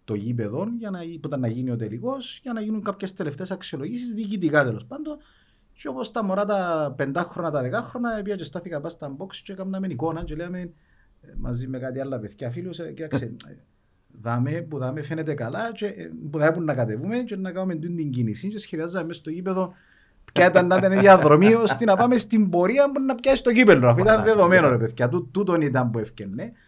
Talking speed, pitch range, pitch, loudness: 200 wpm, 140-200 Hz, 175 Hz, -22 LUFS